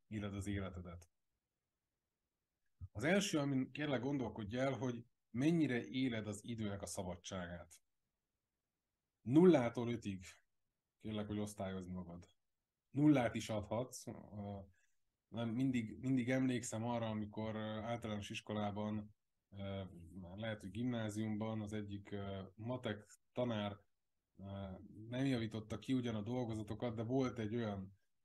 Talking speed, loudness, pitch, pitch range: 105 wpm, -41 LUFS, 110 Hz, 100-120 Hz